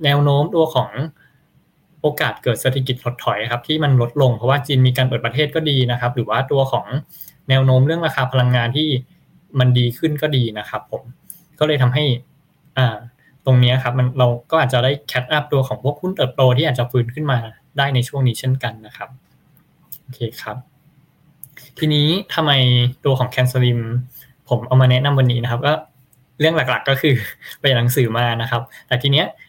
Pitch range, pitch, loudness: 125-145 Hz, 130 Hz, -18 LUFS